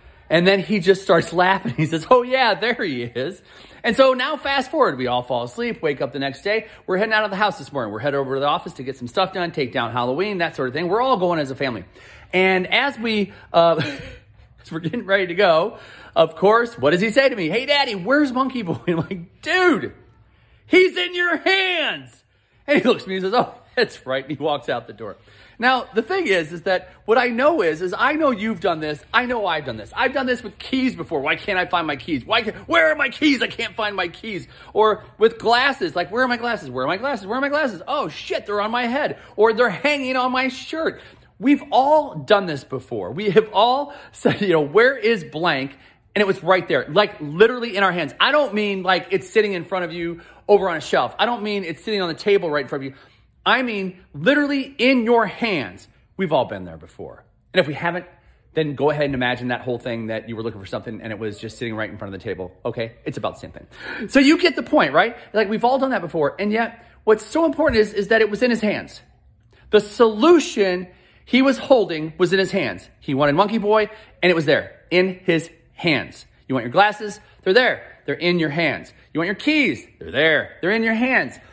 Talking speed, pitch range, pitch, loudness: 250 wpm, 160-250 Hz, 200 Hz, -20 LUFS